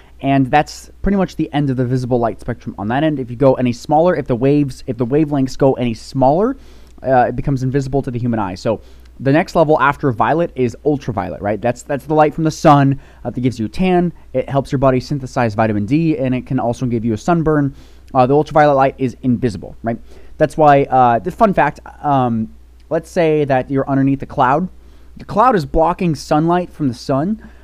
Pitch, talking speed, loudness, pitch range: 135 Hz, 220 wpm, -16 LUFS, 120-150 Hz